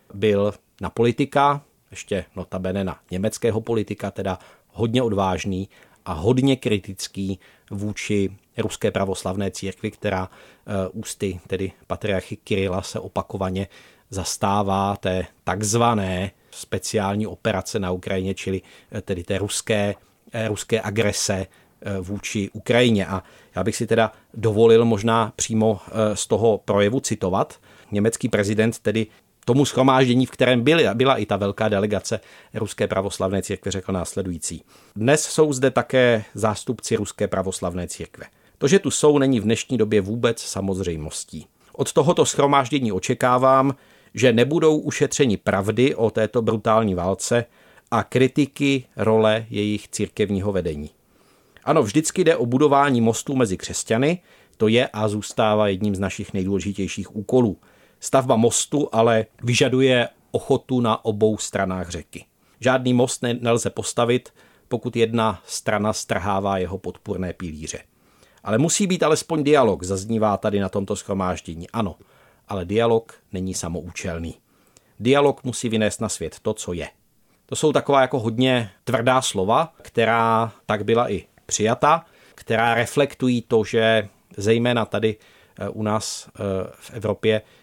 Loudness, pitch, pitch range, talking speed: -22 LUFS, 110 Hz, 95-120 Hz, 130 wpm